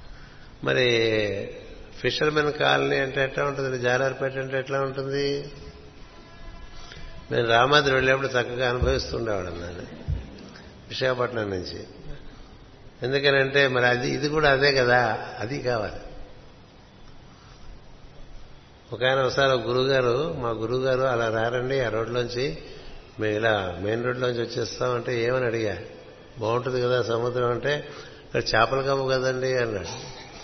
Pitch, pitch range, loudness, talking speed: 125 Hz, 115-135 Hz, -24 LUFS, 110 wpm